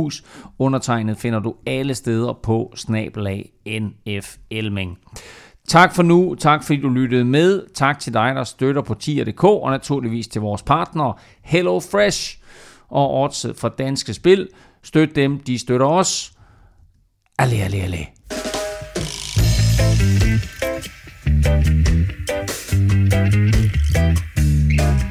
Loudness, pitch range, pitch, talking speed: -19 LUFS, 100-140 Hz, 115 Hz, 100 wpm